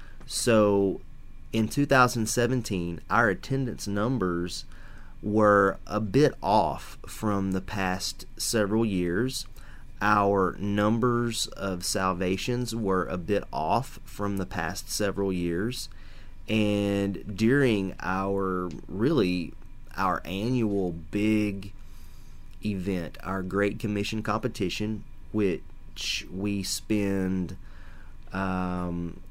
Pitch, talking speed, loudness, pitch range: 100 Hz, 95 wpm, -27 LUFS, 90-110 Hz